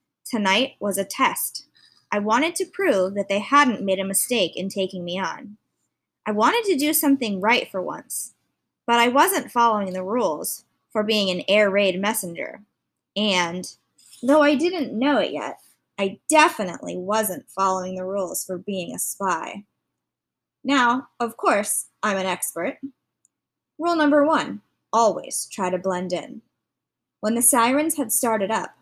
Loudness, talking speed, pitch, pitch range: -22 LUFS, 155 wpm, 215 Hz, 190-275 Hz